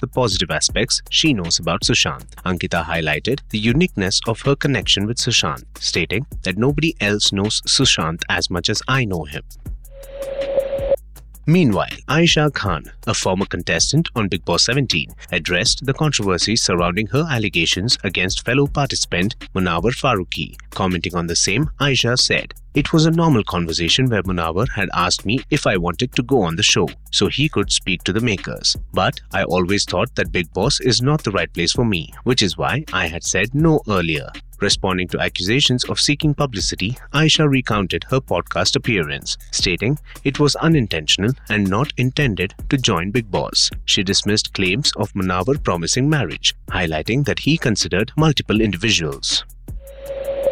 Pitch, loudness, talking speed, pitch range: 110 Hz, -18 LUFS, 165 wpm, 95-140 Hz